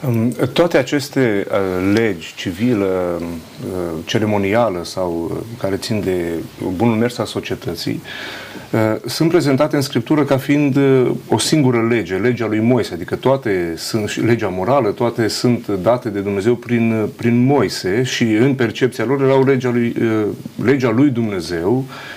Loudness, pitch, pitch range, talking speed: -17 LUFS, 115 Hz, 100-130 Hz, 145 wpm